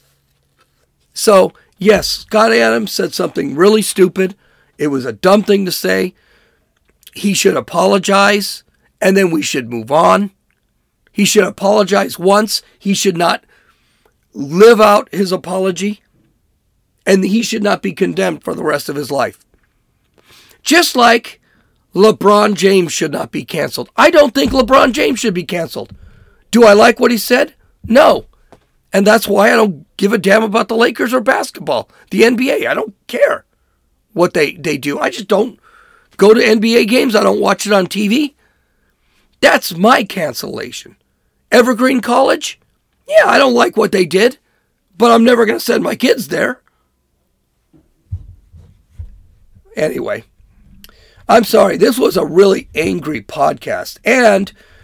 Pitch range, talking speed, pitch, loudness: 160-225 Hz, 150 wpm, 200 Hz, -12 LUFS